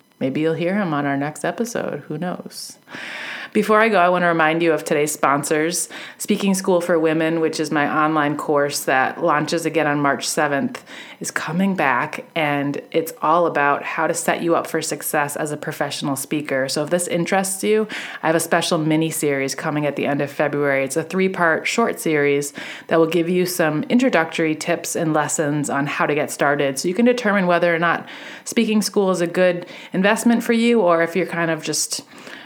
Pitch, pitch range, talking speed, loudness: 160 Hz, 150-180 Hz, 205 wpm, -19 LUFS